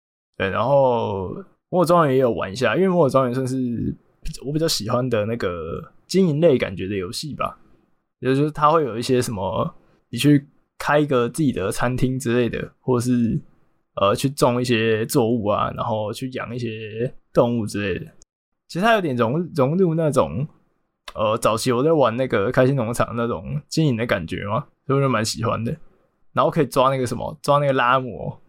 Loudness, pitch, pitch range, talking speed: -21 LUFS, 130 Hz, 115-150 Hz, 280 characters per minute